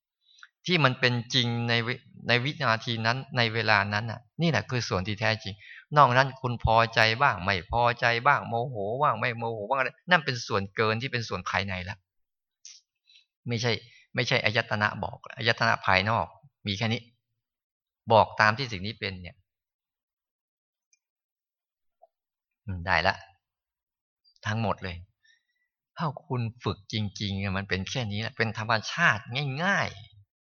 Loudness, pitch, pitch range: -26 LUFS, 115 Hz, 100-125 Hz